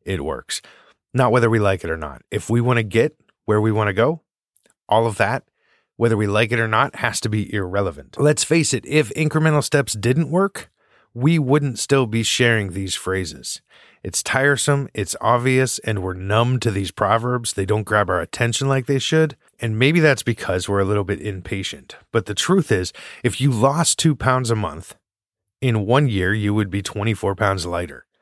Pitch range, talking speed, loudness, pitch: 100-135 Hz, 200 wpm, -20 LUFS, 115 Hz